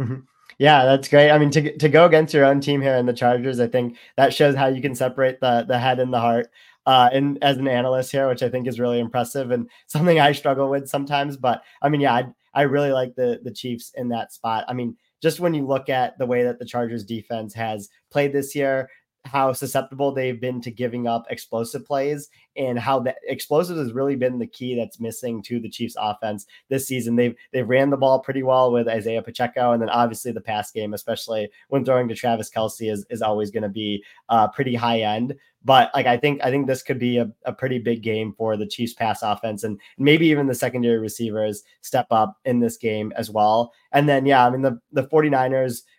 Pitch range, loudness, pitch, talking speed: 115-135 Hz, -21 LUFS, 125 Hz, 230 wpm